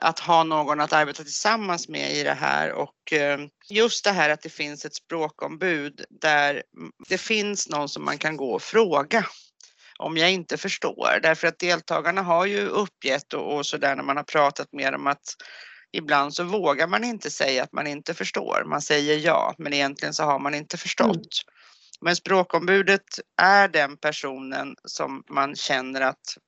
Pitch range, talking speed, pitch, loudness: 145-180 Hz, 175 wpm, 155 Hz, -23 LUFS